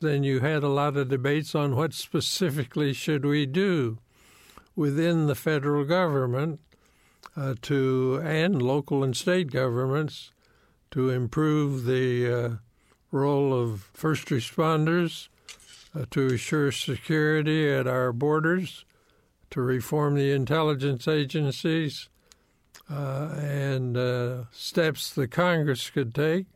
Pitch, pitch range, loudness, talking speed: 145 Hz, 130-155 Hz, -26 LUFS, 120 wpm